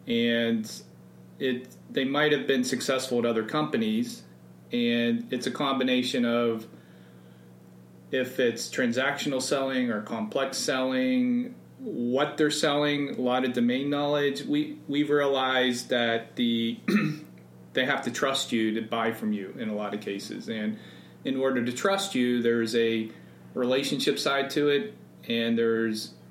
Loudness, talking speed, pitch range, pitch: -27 LUFS, 145 wpm, 110-140 Hz, 120 Hz